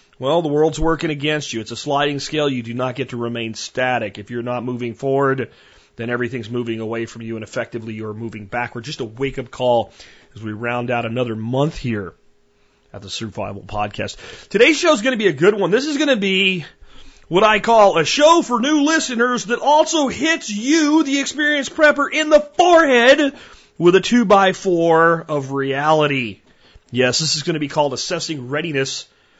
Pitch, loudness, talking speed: 145 Hz, -17 LUFS, 200 wpm